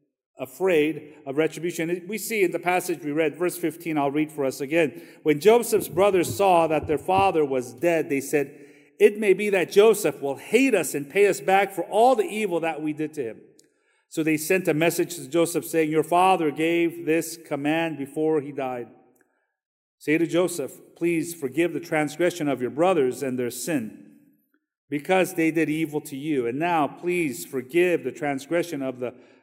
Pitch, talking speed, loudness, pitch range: 160 Hz, 190 wpm, -24 LUFS, 145-180 Hz